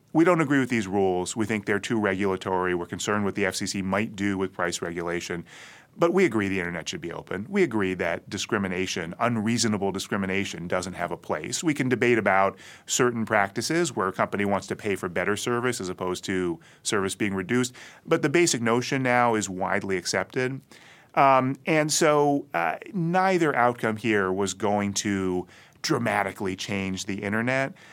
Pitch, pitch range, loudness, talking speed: 105 Hz, 95-125 Hz, -25 LUFS, 175 wpm